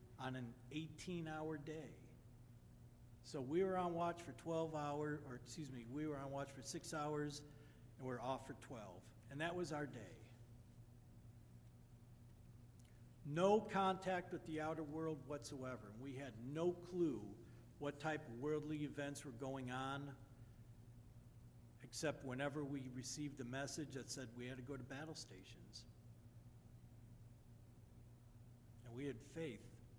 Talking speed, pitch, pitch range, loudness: 145 wpm, 130 Hz, 120-150 Hz, -47 LUFS